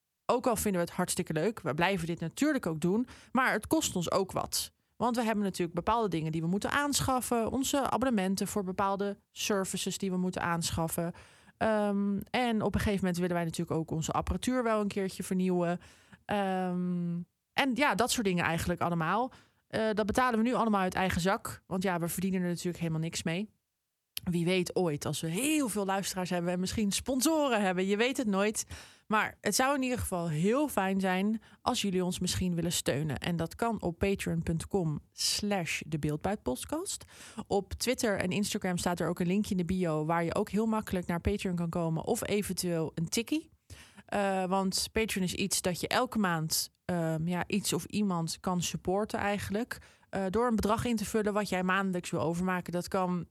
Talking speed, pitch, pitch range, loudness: 195 wpm, 190 Hz, 175-215 Hz, -31 LUFS